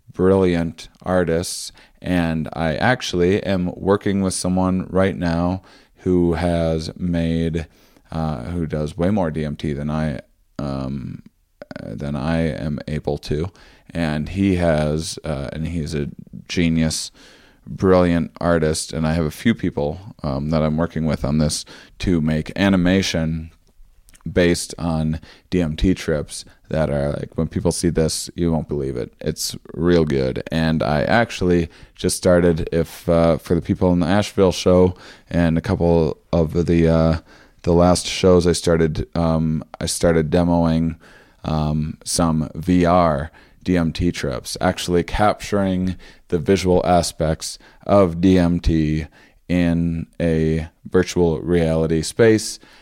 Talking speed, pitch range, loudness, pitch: 135 wpm, 80-90 Hz, -20 LUFS, 85 Hz